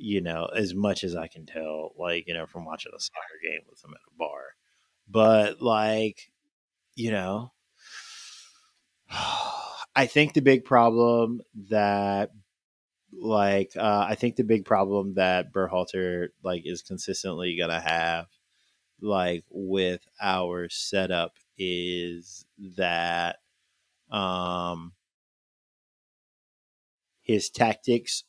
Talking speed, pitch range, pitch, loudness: 115 wpm, 90-115 Hz, 95 Hz, -27 LUFS